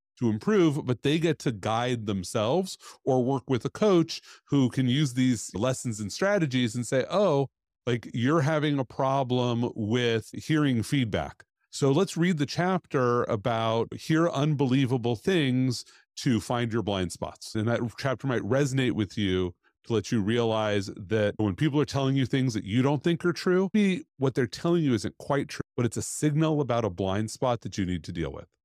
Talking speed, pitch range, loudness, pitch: 190 wpm, 115-145 Hz, -27 LUFS, 130 Hz